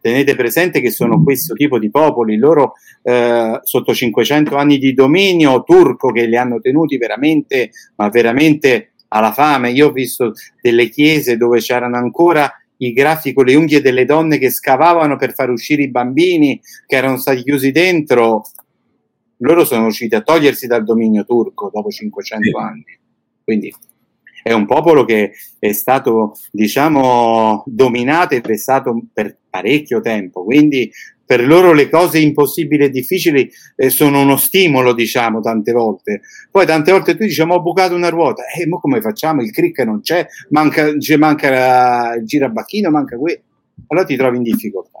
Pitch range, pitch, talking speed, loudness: 120-160 Hz, 140 Hz, 160 wpm, -13 LUFS